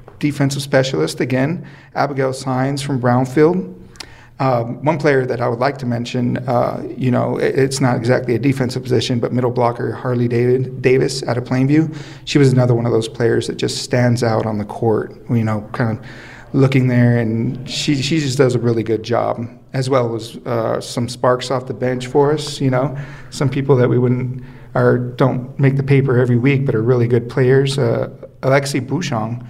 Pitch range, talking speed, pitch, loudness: 120-135 Hz, 195 wpm, 125 Hz, -17 LUFS